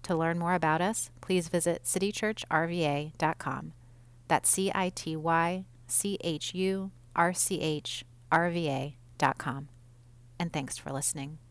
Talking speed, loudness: 135 wpm, -30 LUFS